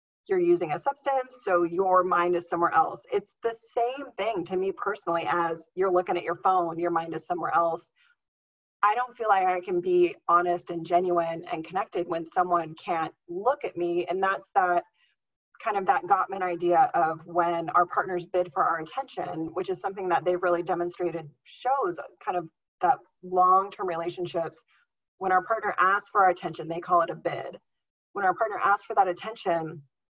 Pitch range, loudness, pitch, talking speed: 170-210 Hz, -27 LUFS, 180 Hz, 185 wpm